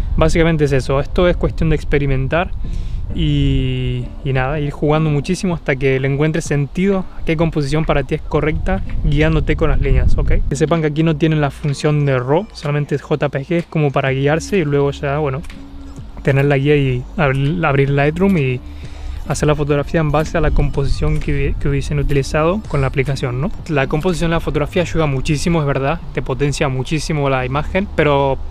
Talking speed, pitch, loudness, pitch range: 195 wpm, 145 Hz, -17 LUFS, 135-160 Hz